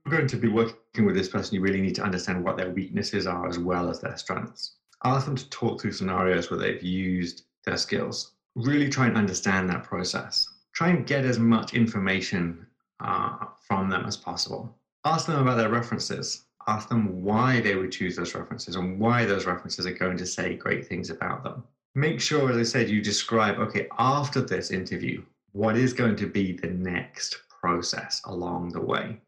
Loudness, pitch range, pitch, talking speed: -27 LUFS, 95-125 Hz, 105 Hz, 195 wpm